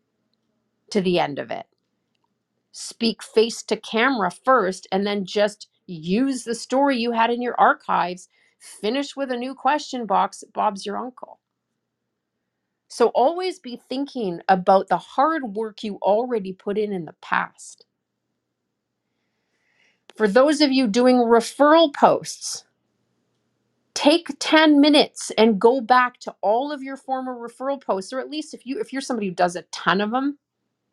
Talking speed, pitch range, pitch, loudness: 150 wpm, 205-270 Hz, 235 Hz, -21 LUFS